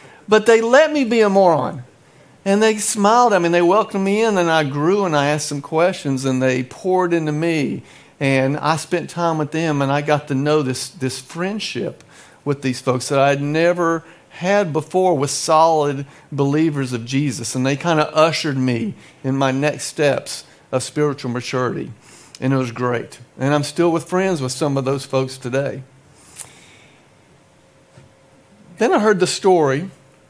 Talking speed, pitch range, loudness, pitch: 180 wpm, 135-175 Hz, -18 LUFS, 150 Hz